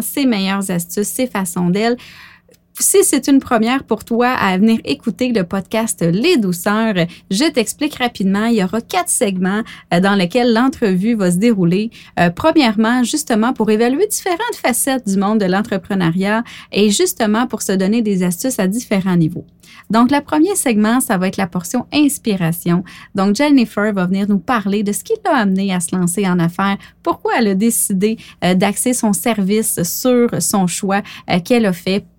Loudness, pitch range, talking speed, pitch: -16 LUFS, 195-245 Hz, 175 wpm, 215 Hz